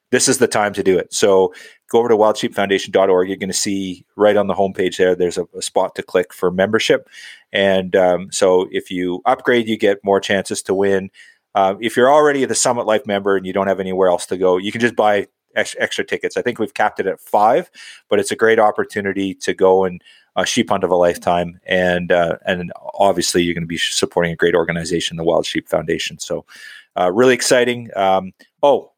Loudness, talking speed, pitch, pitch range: -17 LUFS, 220 wpm, 100 Hz, 95-115 Hz